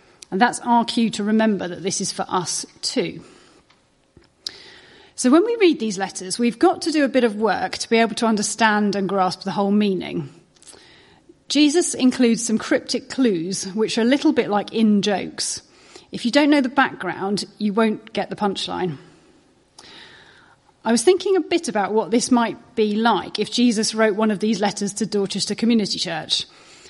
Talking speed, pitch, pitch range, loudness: 185 wpm, 220 Hz, 200-245 Hz, -20 LUFS